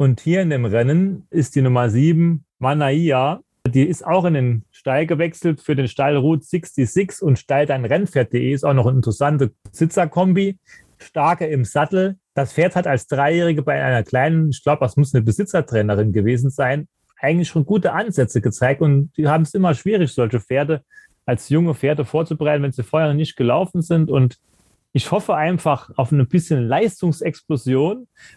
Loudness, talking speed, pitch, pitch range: -18 LUFS, 170 wpm, 150 Hz, 130-170 Hz